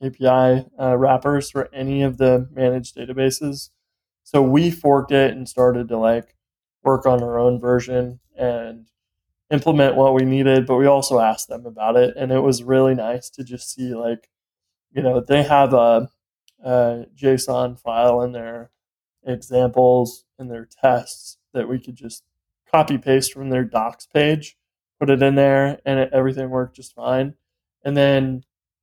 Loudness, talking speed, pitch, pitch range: -19 LUFS, 165 wpm, 130 Hz, 120-135 Hz